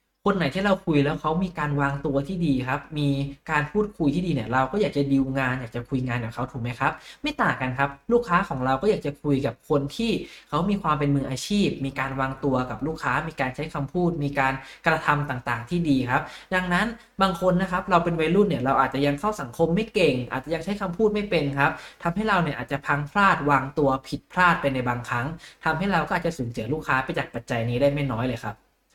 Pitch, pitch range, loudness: 145 Hz, 135-175 Hz, -25 LUFS